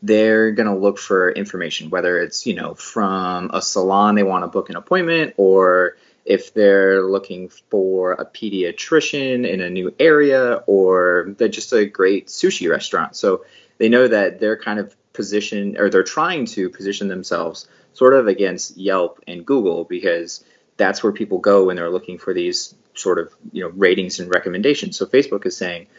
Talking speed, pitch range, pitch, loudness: 180 wpm, 95-150 Hz, 100 Hz, -18 LUFS